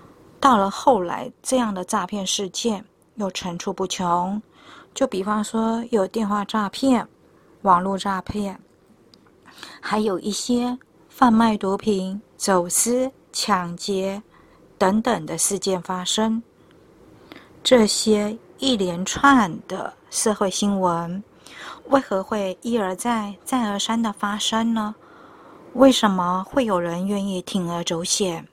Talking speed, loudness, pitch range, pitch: 175 characters per minute, -22 LUFS, 190-225 Hz, 205 Hz